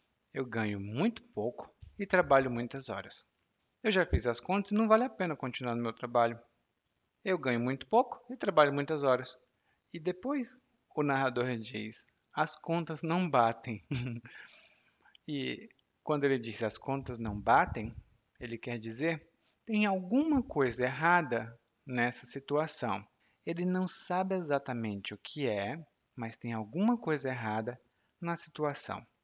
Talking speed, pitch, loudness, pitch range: 145 wpm, 130 Hz, -33 LUFS, 115-170 Hz